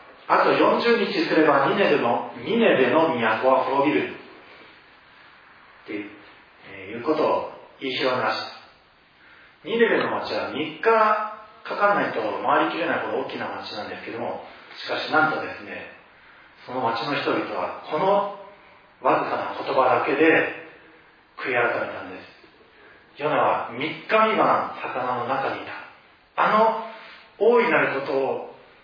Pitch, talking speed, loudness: 220 Hz, 255 characters per minute, -22 LUFS